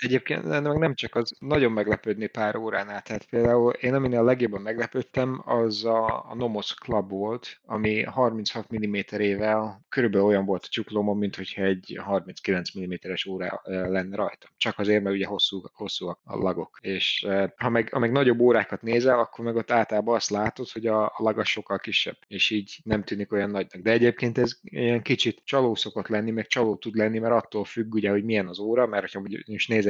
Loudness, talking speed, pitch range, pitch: -26 LUFS, 195 wpm, 100-120 Hz, 110 Hz